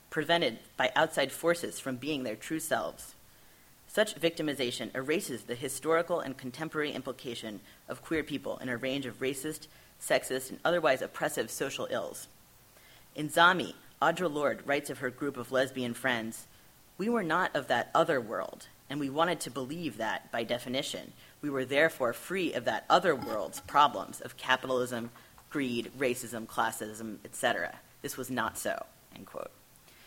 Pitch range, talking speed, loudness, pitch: 120-155 Hz, 155 wpm, -32 LUFS, 135 Hz